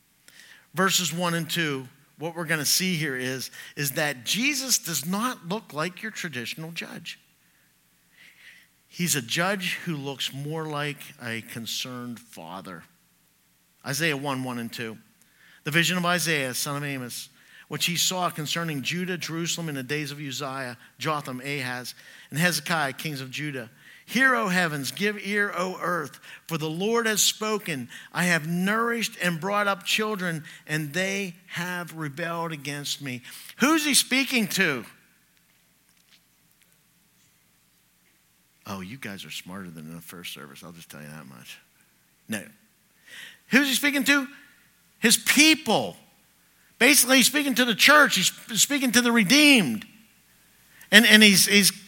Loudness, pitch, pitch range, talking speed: -23 LUFS, 165 Hz, 130-205 Hz, 150 wpm